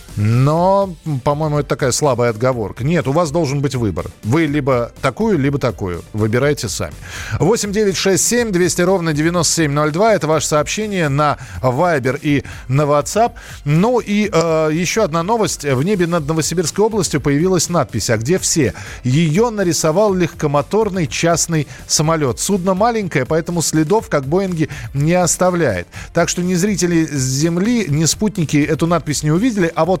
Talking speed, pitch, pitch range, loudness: 145 wpm, 160 Hz, 140-180 Hz, -16 LUFS